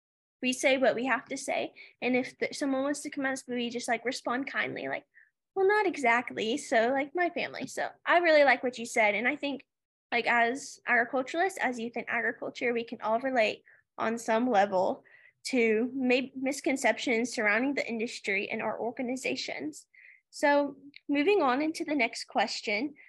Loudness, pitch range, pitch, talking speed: -29 LUFS, 235-290 Hz, 255 Hz, 175 wpm